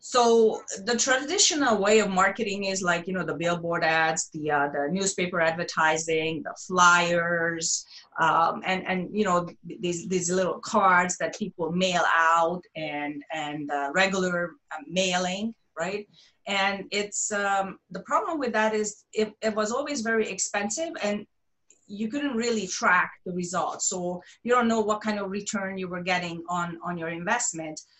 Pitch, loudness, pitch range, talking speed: 185 Hz, -26 LUFS, 170-215 Hz, 160 wpm